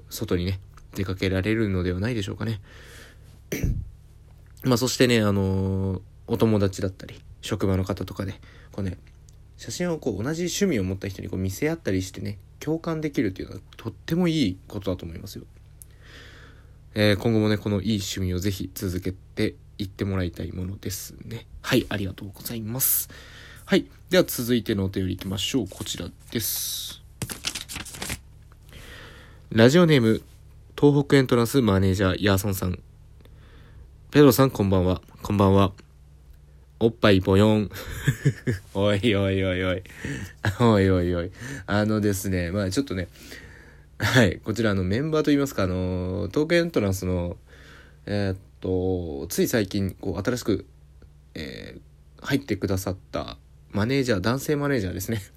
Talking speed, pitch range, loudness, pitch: 330 characters per minute, 95-115 Hz, -24 LUFS, 100 Hz